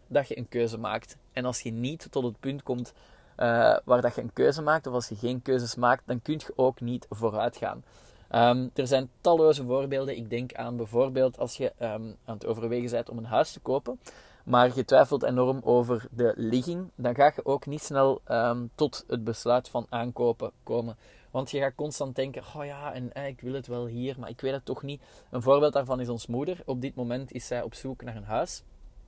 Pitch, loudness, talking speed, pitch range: 125 Hz, -28 LUFS, 225 wpm, 120-135 Hz